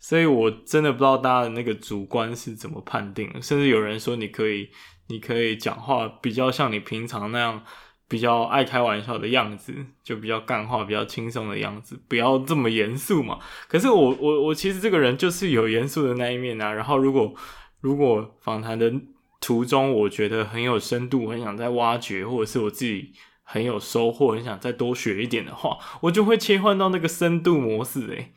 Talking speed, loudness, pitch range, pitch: 305 characters per minute, -23 LUFS, 110-135 Hz, 120 Hz